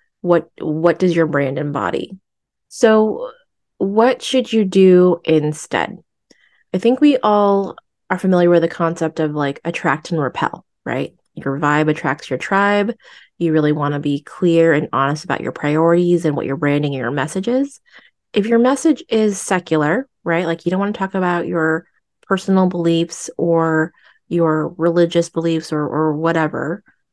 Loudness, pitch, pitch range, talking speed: -17 LUFS, 170 Hz, 155-195 Hz, 165 wpm